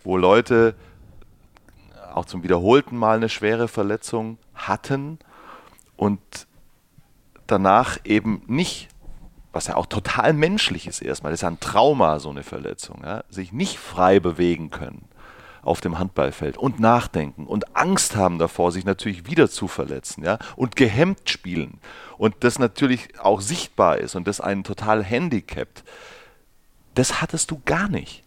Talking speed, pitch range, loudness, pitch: 145 wpm, 90-120 Hz, -21 LUFS, 105 Hz